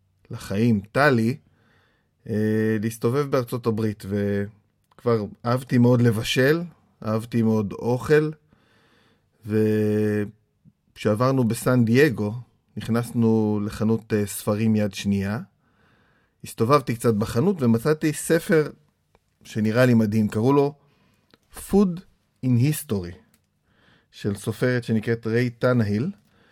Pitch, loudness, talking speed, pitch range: 115 Hz, -23 LUFS, 90 wpm, 110-130 Hz